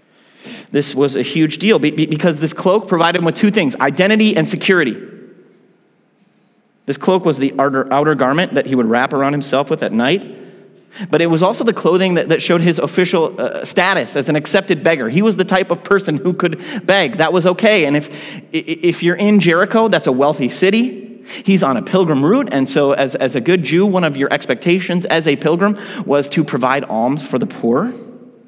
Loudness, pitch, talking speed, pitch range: -15 LUFS, 170 Hz, 200 wpm, 145-190 Hz